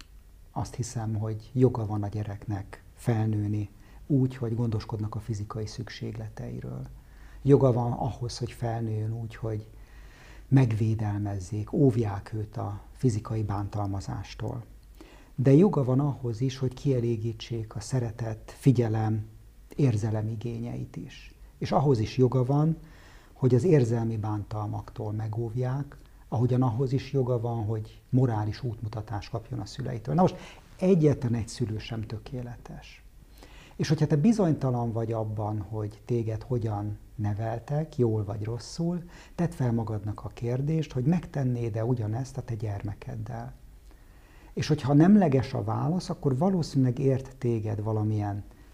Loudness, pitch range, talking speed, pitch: -28 LUFS, 105-130 Hz, 125 wpm, 115 Hz